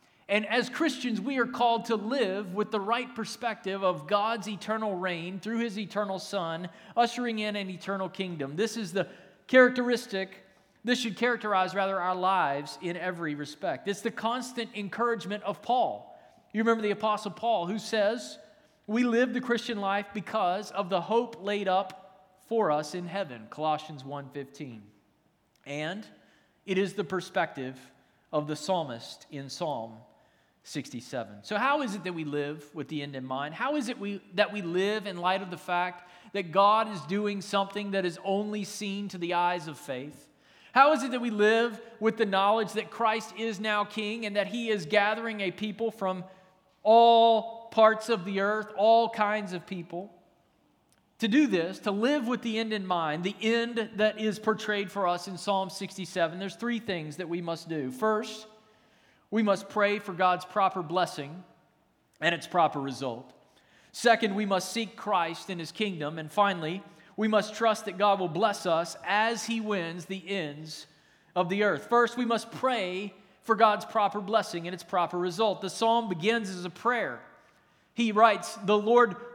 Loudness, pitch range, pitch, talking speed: -29 LUFS, 180-225 Hz, 200 Hz, 180 wpm